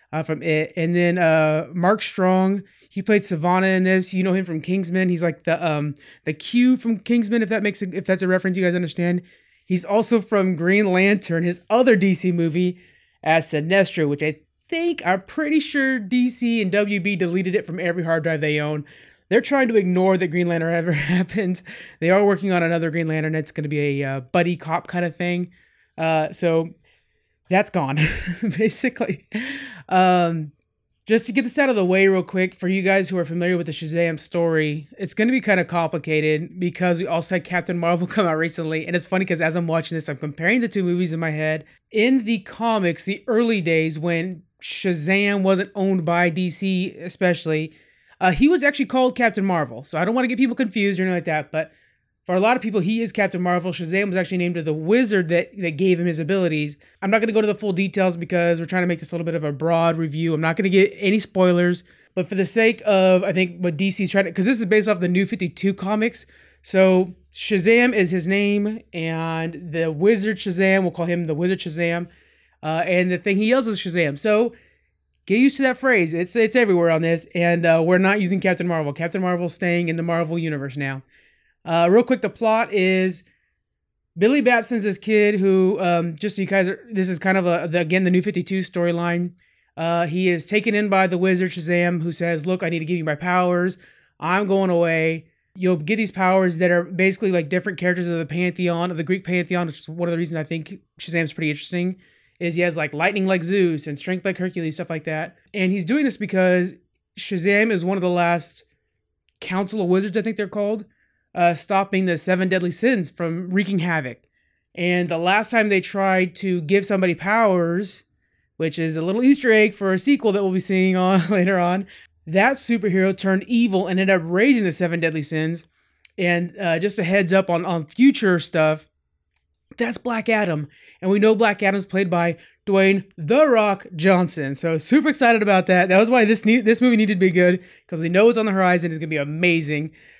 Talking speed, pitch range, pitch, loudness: 220 wpm, 170-200 Hz, 180 Hz, -20 LUFS